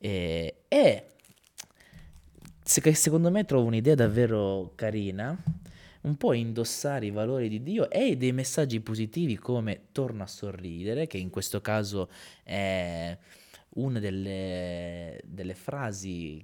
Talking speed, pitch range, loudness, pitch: 120 wpm, 95-125 Hz, -29 LUFS, 105 Hz